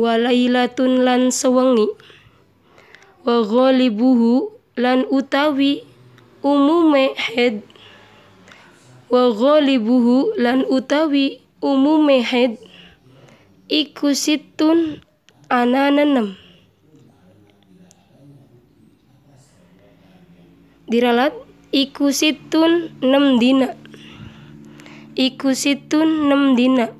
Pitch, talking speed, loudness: 250 Hz, 55 wpm, -17 LUFS